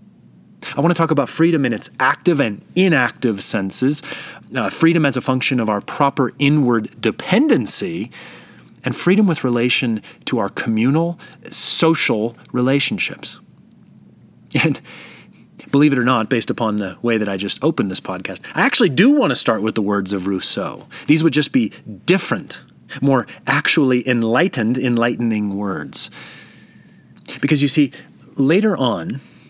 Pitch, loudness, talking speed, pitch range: 130 Hz, -17 LUFS, 145 wpm, 115-150 Hz